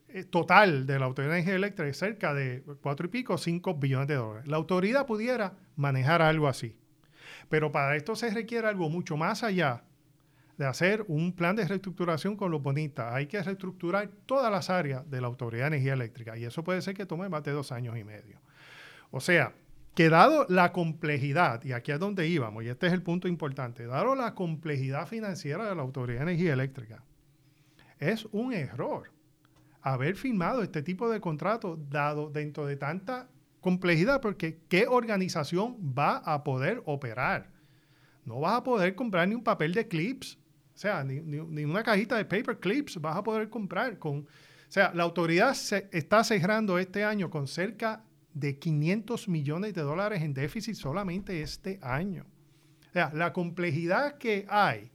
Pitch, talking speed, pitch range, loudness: 165 Hz, 180 wpm, 145-195 Hz, -30 LUFS